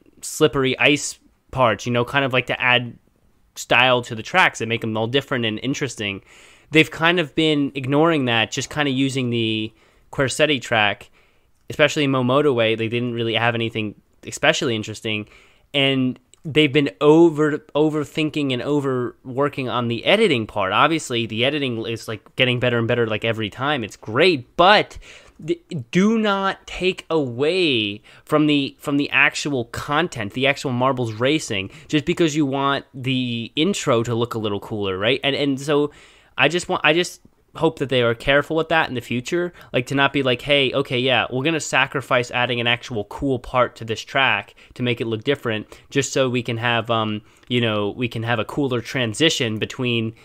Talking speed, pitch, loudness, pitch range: 185 wpm, 130 Hz, -20 LUFS, 115-145 Hz